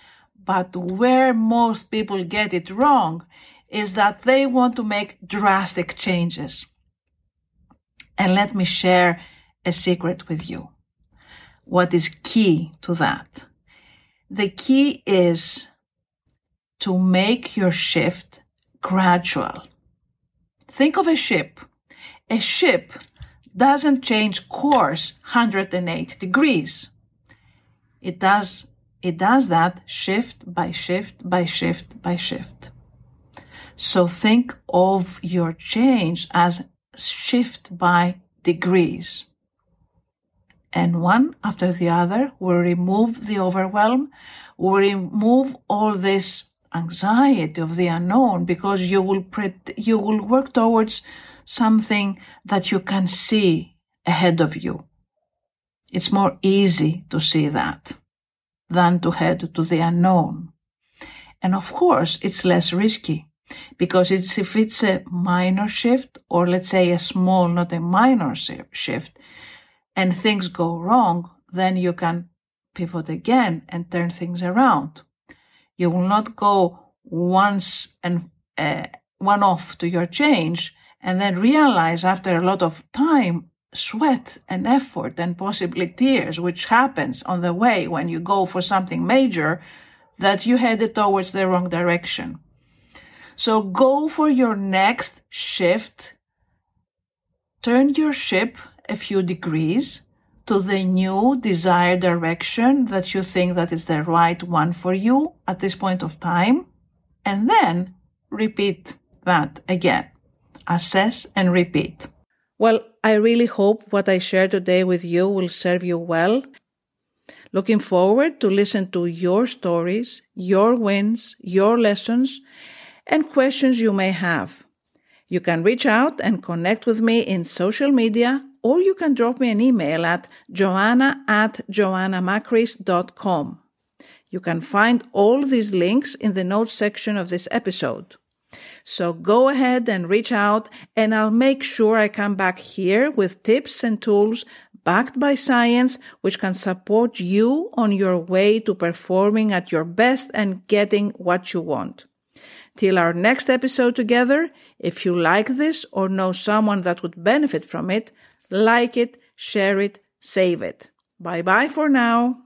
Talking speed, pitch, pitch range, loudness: 135 wpm, 195 Hz, 175-230 Hz, -20 LUFS